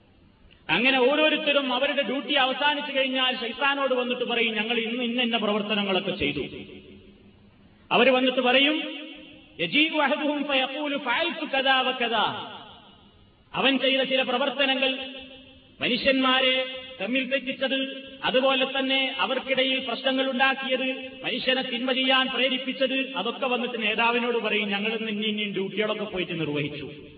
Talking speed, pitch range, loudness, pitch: 95 wpm, 225-270 Hz, -24 LUFS, 260 Hz